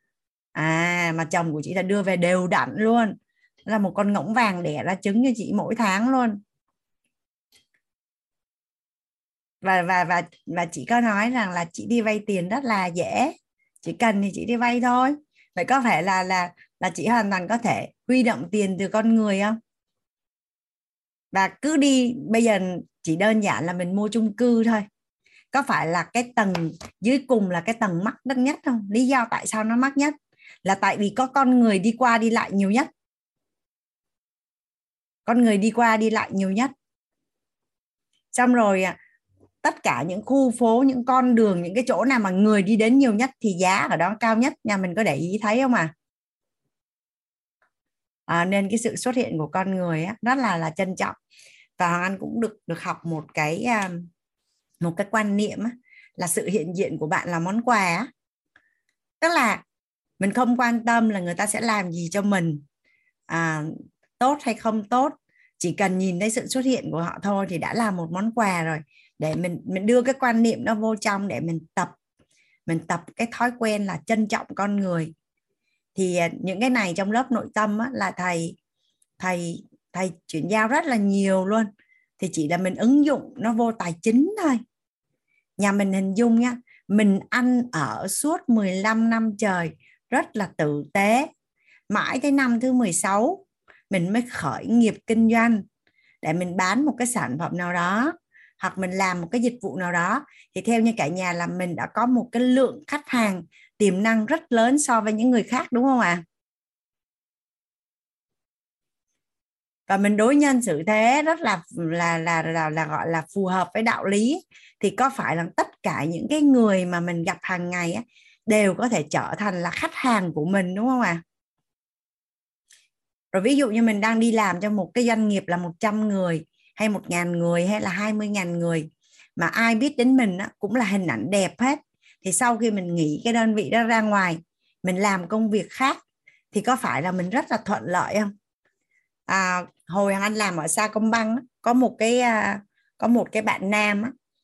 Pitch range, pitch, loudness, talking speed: 185-240 Hz, 215 Hz, -23 LUFS, 200 wpm